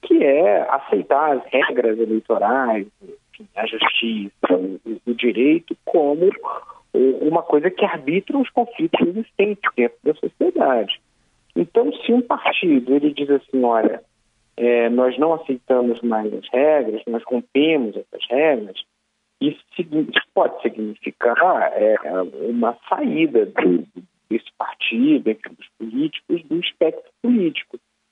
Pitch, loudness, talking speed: 155 Hz, -19 LUFS, 115 wpm